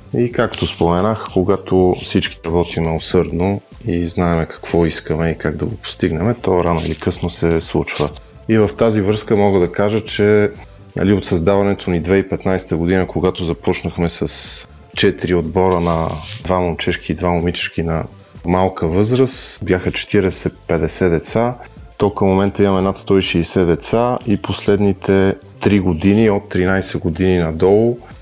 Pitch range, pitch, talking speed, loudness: 85-100 Hz, 95 Hz, 140 wpm, -17 LUFS